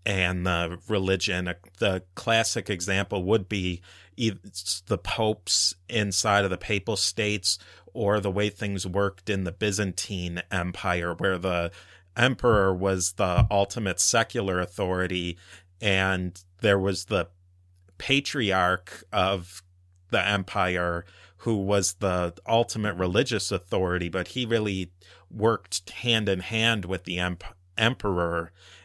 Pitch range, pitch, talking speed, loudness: 90-105 Hz, 95 Hz, 120 wpm, -26 LUFS